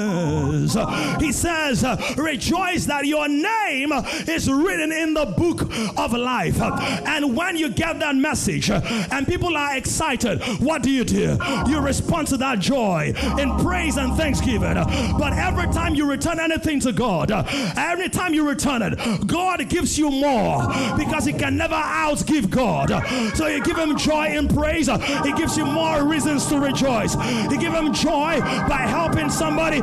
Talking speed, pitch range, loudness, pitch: 160 wpm, 250-315 Hz, -21 LUFS, 290 Hz